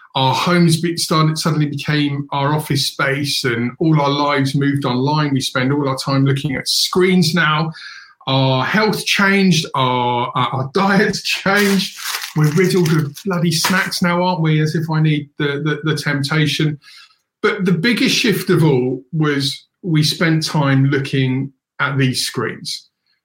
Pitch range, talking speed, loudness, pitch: 140-175 Hz, 160 wpm, -16 LUFS, 150 Hz